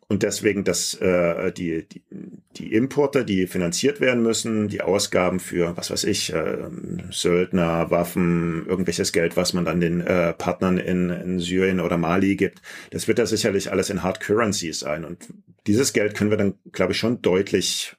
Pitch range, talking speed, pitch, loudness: 85-105 Hz, 180 wpm, 90 Hz, -22 LUFS